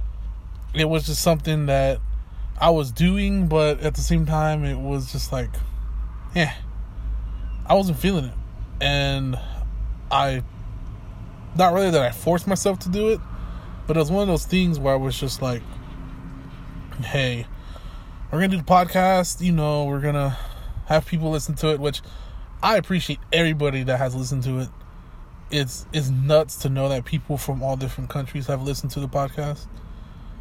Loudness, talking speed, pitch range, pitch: -23 LUFS, 170 wpm, 110-155 Hz, 140 Hz